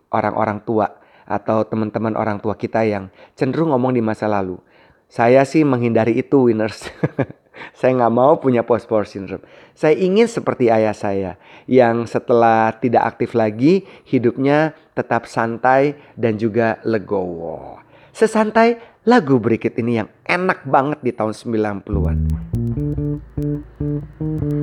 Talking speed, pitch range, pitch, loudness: 125 wpm, 110-145 Hz, 115 Hz, -18 LUFS